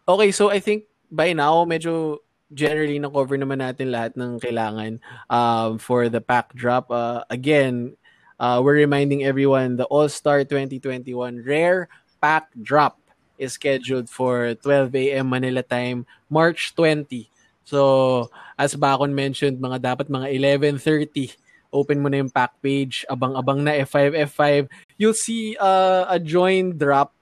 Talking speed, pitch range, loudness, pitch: 145 wpm, 125-150 Hz, -21 LUFS, 140 Hz